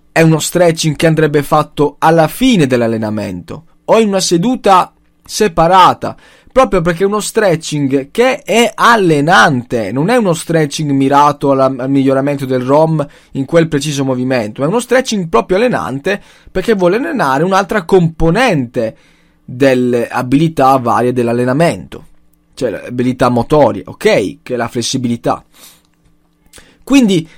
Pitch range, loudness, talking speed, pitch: 130-175 Hz, -12 LUFS, 130 wpm, 150 Hz